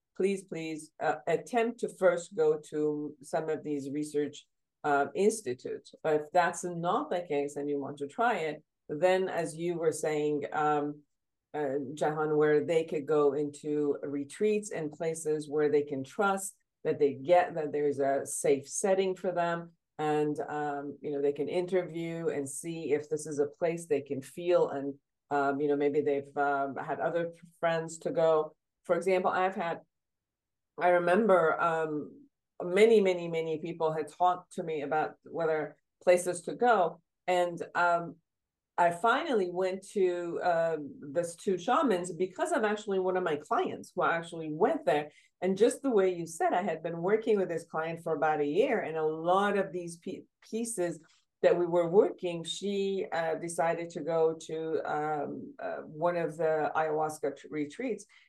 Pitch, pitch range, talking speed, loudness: 165 Hz, 150-180 Hz, 175 wpm, -31 LUFS